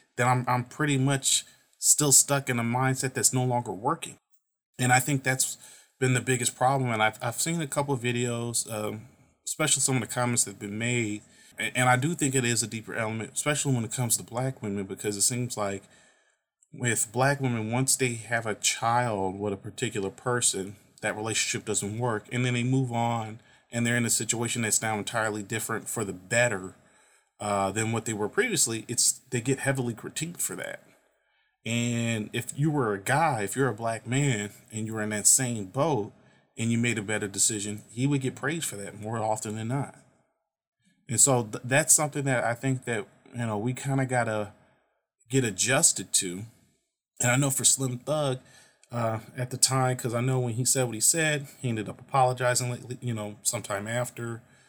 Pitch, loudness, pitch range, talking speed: 120 Hz, -26 LUFS, 110-130 Hz, 205 wpm